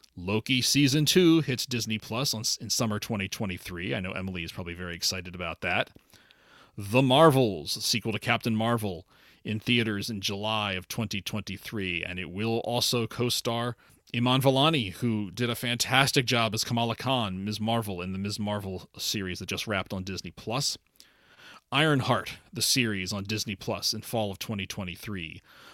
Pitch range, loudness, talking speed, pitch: 95-120 Hz, -27 LUFS, 165 wpm, 110 Hz